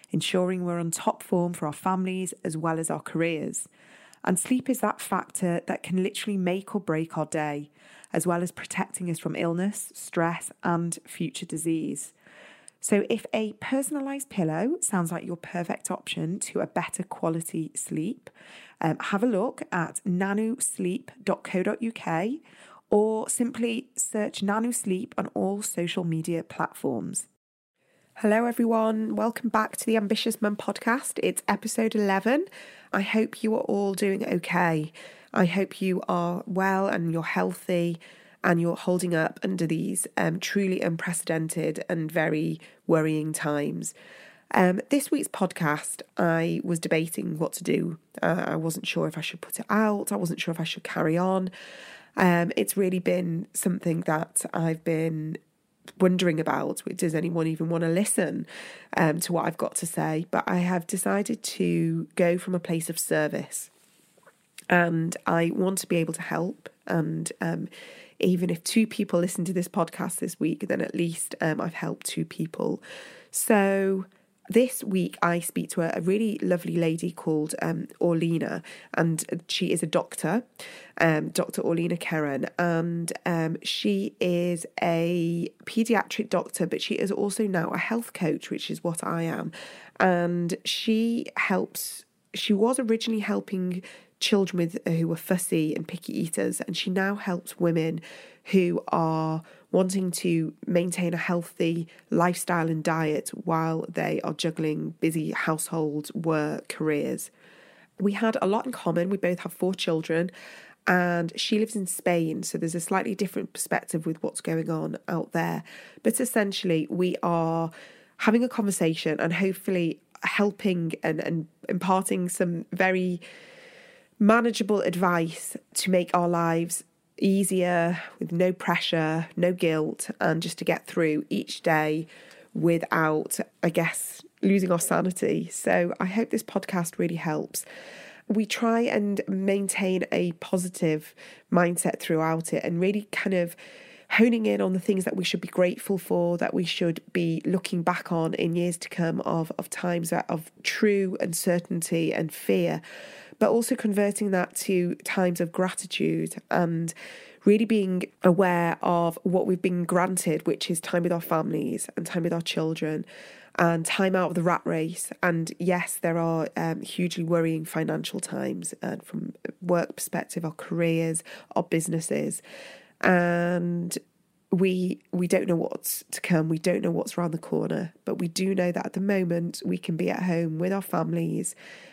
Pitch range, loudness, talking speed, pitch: 165-200 Hz, -27 LUFS, 160 wpm, 180 Hz